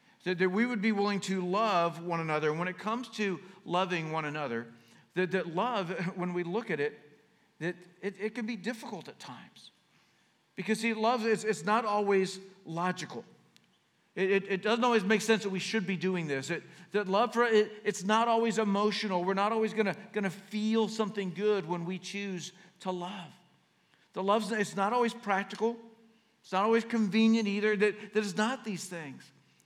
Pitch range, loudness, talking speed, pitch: 185-220 Hz, -31 LUFS, 190 wpm, 200 Hz